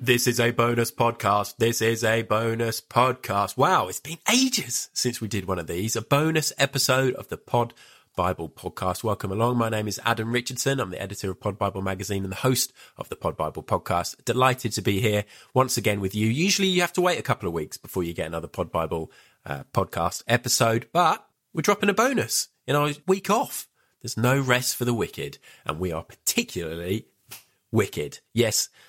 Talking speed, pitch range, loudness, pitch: 200 wpm, 100-135 Hz, -25 LUFS, 120 Hz